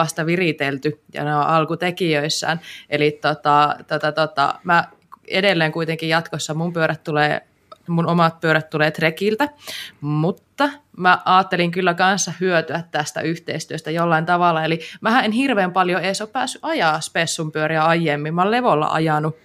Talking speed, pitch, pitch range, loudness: 150 wpm, 165 Hz, 155-180 Hz, -19 LUFS